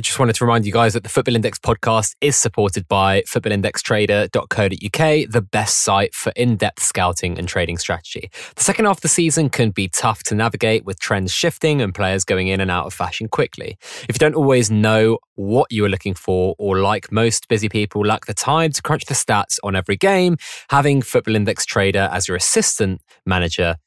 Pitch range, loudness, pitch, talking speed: 95-120 Hz, -18 LUFS, 110 Hz, 200 wpm